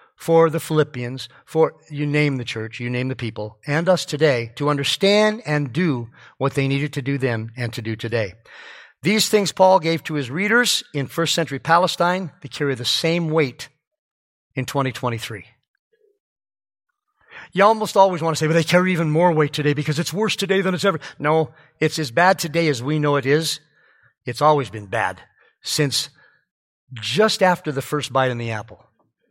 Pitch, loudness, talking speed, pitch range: 150 Hz, -20 LUFS, 185 wpm, 130-175 Hz